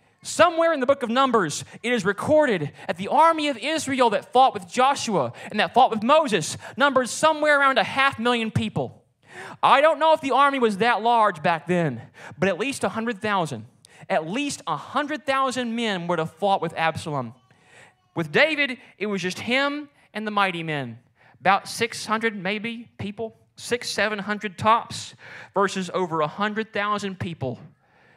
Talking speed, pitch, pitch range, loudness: 160 wpm, 210 Hz, 170-260 Hz, -22 LUFS